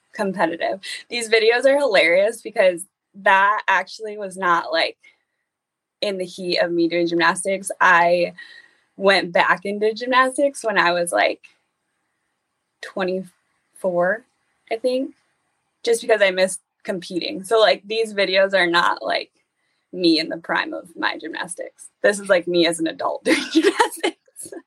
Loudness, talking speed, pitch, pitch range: -19 LUFS, 140 wpm, 200 Hz, 180-270 Hz